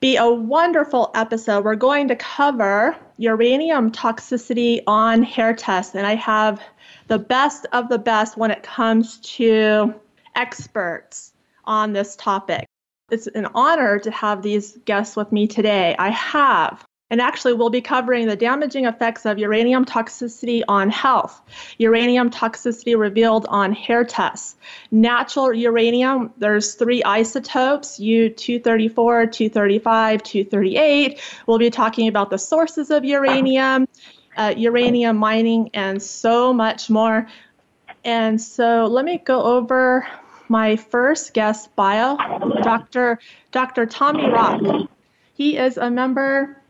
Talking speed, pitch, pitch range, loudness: 130 wpm, 230 Hz, 215-255 Hz, -18 LUFS